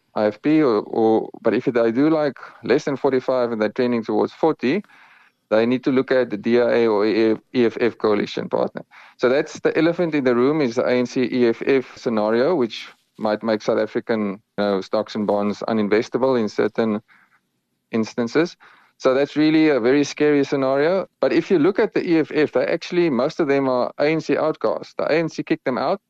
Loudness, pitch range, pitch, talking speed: -20 LUFS, 110-150 Hz, 125 Hz, 185 wpm